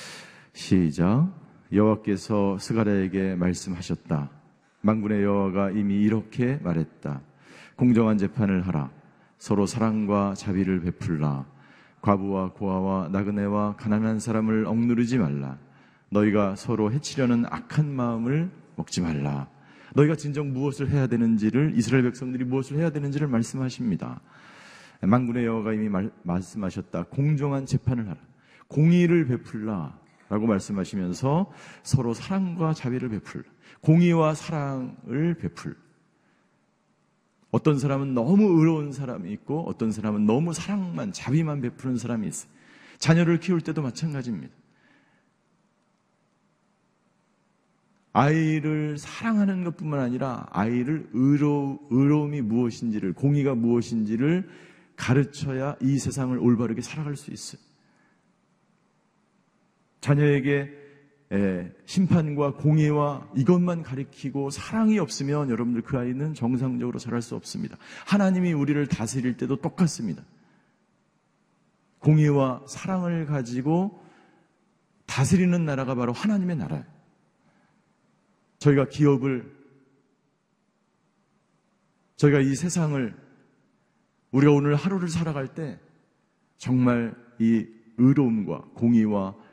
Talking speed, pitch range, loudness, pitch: 275 characters per minute, 110-160 Hz, -25 LUFS, 135 Hz